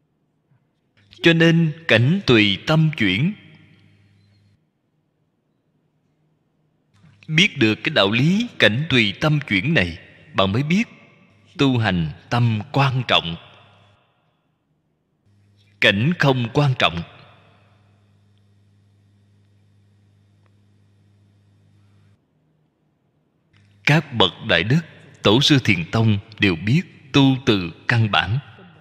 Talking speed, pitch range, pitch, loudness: 85 wpm, 100-150 Hz, 115 Hz, -18 LUFS